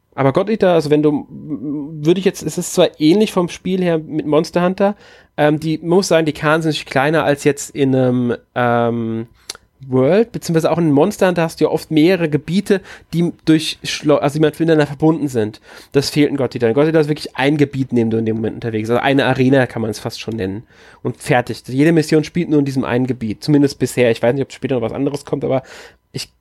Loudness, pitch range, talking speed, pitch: -16 LUFS, 130-160 Hz, 235 wpm, 145 Hz